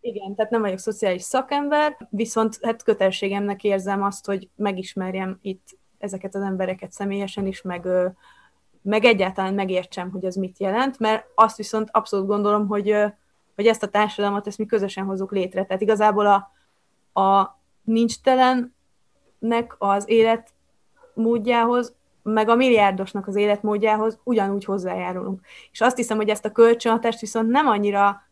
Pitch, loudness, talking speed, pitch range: 210 Hz, -22 LUFS, 140 wpm, 195-225 Hz